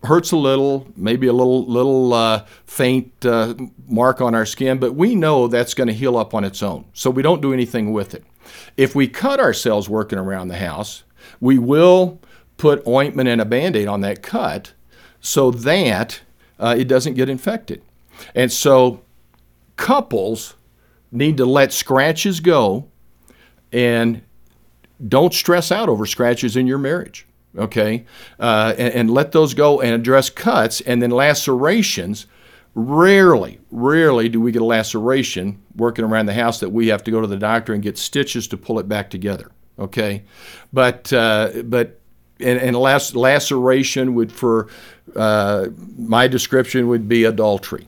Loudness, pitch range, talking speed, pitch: -17 LUFS, 110-135 Hz, 165 wpm, 120 Hz